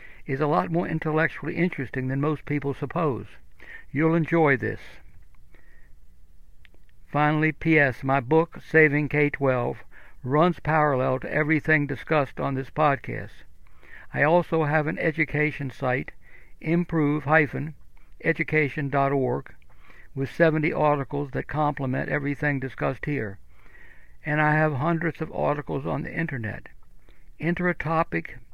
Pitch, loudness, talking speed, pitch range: 150 Hz, -25 LUFS, 120 wpm, 135-160 Hz